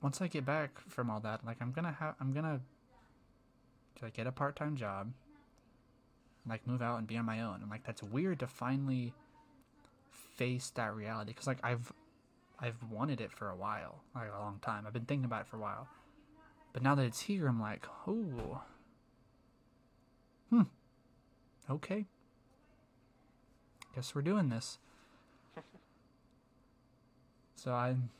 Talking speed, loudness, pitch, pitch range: 155 wpm, -39 LUFS, 130 Hz, 120-135 Hz